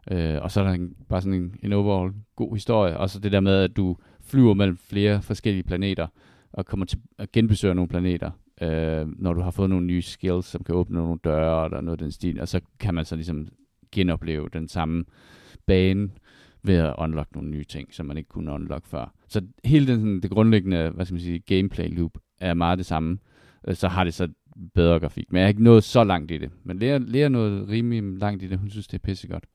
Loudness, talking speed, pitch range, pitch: -24 LUFS, 235 wpm, 85-100 Hz, 95 Hz